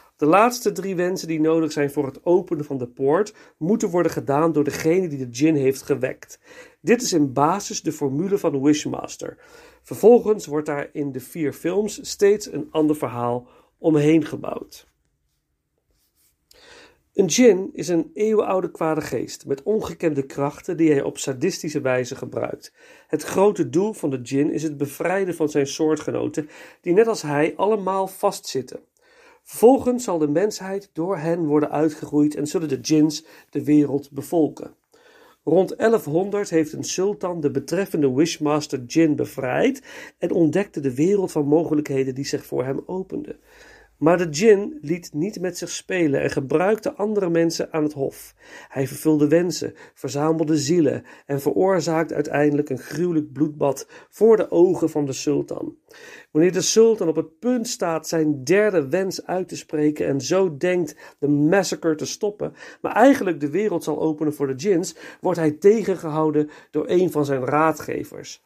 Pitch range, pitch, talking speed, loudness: 150-190 Hz, 160 Hz, 160 wpm, -21 LUFS